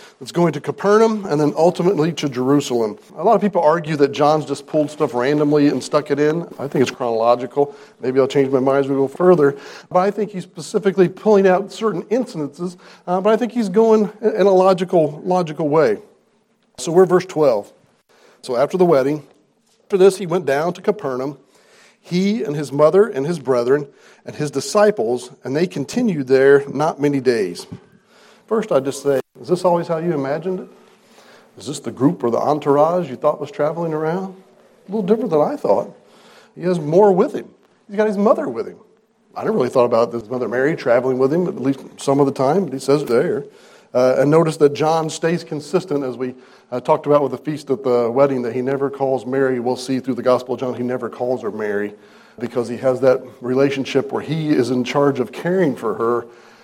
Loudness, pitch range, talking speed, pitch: -18 LUFS, 130-180 Hz, 210 wpm, 150 Hz